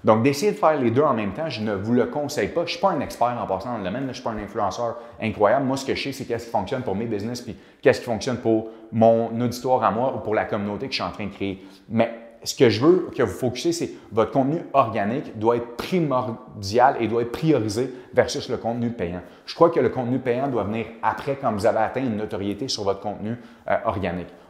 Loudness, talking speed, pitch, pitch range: -23 LUFS, 265 wpm, 115 Hz, 110-135 Hz